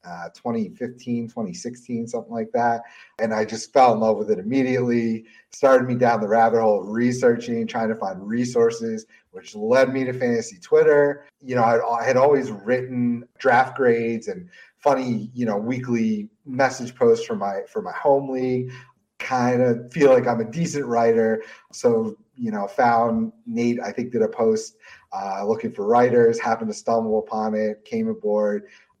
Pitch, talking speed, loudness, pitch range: 120 Hz, 170 wpm, -22 LUFS, 115-145 Hz